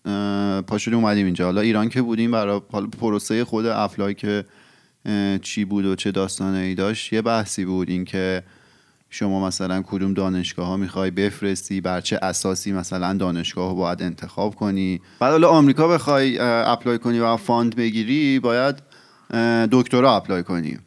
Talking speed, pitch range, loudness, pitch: 150 wpm, 95-115 Hz, -21 LUFS, 100 Hz